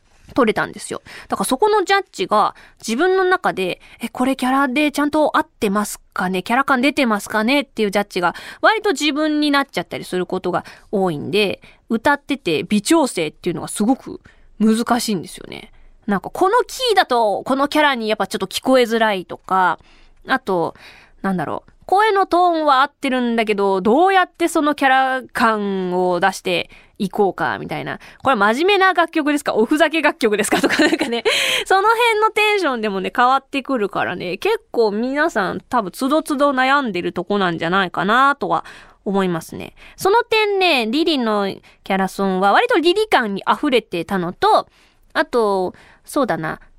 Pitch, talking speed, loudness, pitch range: 260 Hz, 370 characters per minute, -18 LUFS, 200-315 Hz